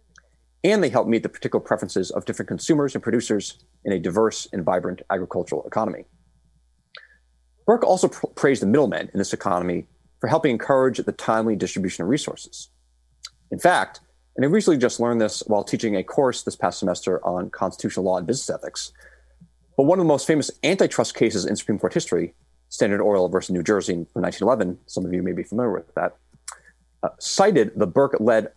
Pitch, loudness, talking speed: 90 Hz, -22 LUFS, 185 wpm